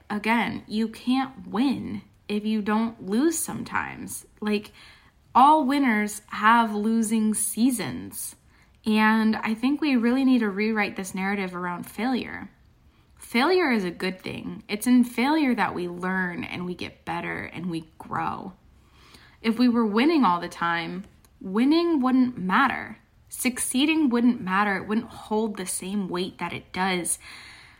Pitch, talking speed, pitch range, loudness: 220 Hz, 145 wpm, 190-250 Hz, -24 LUFS